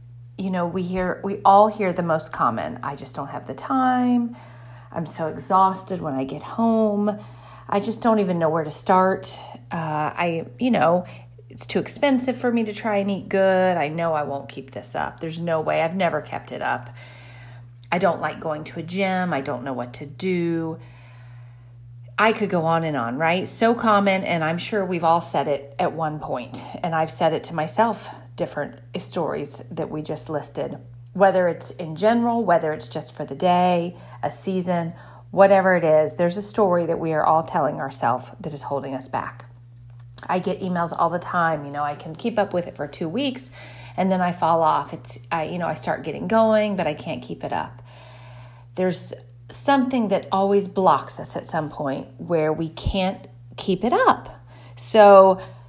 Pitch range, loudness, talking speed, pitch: 130-185 Hz, -22 LUFS, 200 wpm, 160 Hz